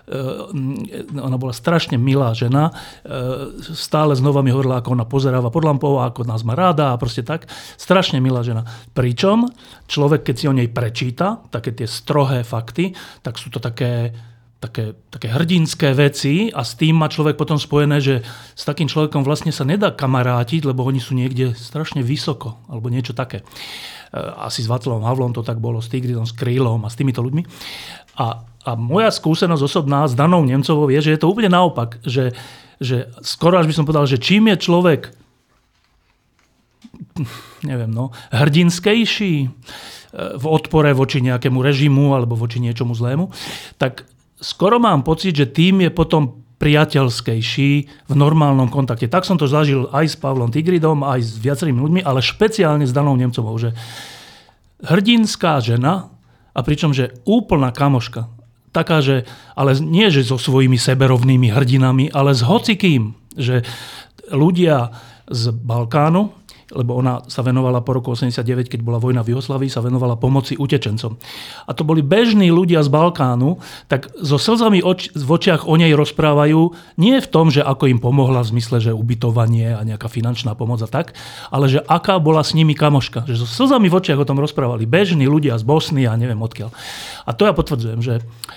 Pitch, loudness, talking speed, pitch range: 135 Hz, -17 LUFS, 170 wpm, 125-155 Hz